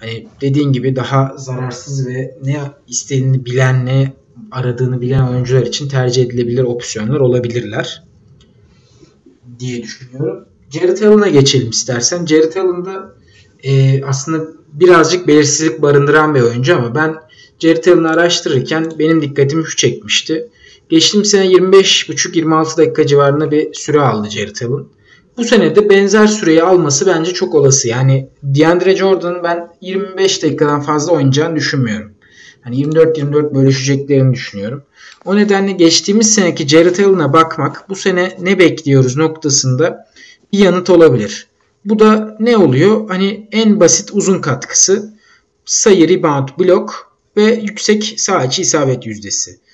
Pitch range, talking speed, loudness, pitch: 130-180 Hz, 125 wpm, -12 LUFS, 155 Hz